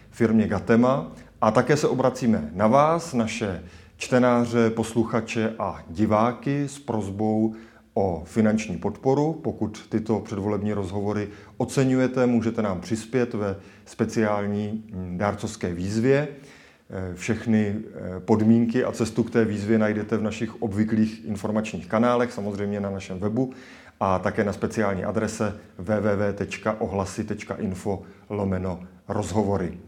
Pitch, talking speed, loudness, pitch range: 110 Hz, 110 wpm, -25 LUFS, 100-115 Hz